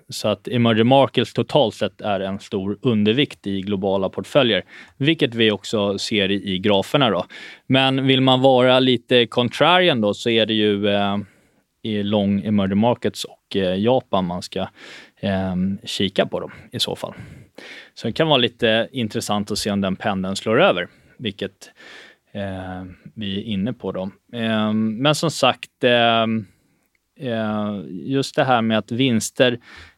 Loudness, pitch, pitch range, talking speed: -20 LUFS, 110 Hz, 100-125 Hz, 160 wpm